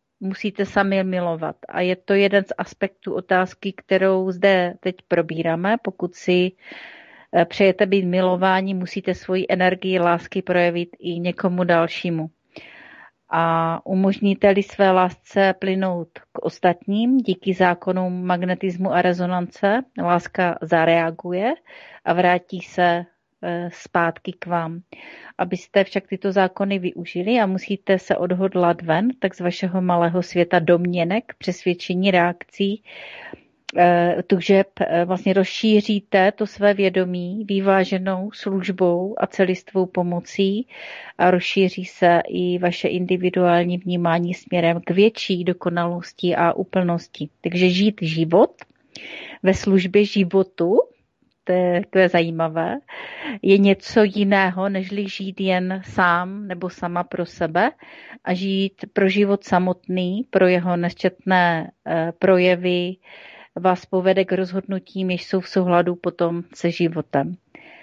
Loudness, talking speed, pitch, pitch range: -20 LUFS, 115 wpm, 185 Hz, 175-195 Hz